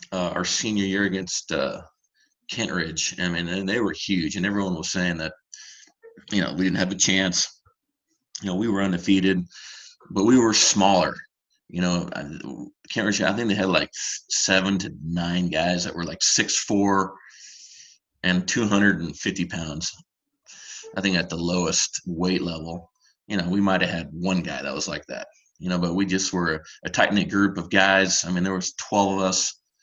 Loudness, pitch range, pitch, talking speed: -23 LUFS, 90-100 Hz, 95 Hz, 195 wpm